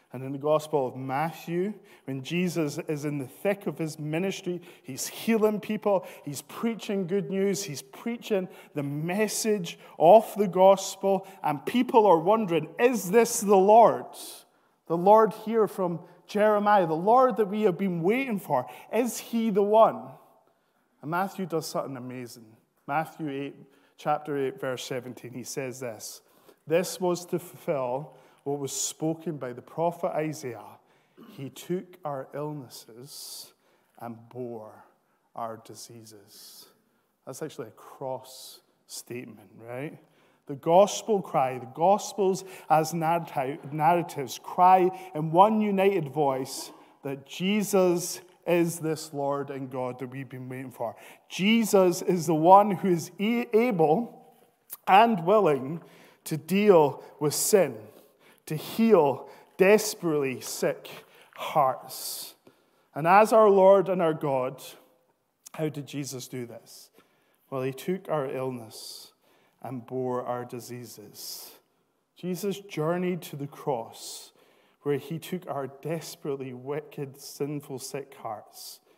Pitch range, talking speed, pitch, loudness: 135-195 Hz, 130 wpm, 165 Hz, -26 LUFS